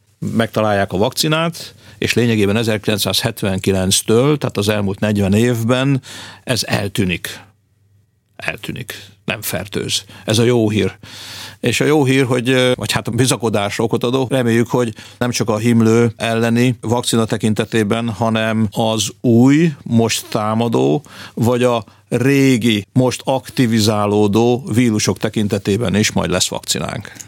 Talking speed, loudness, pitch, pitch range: 125 wpm, -16 LUFS, 115 Hz, 105-120 Hz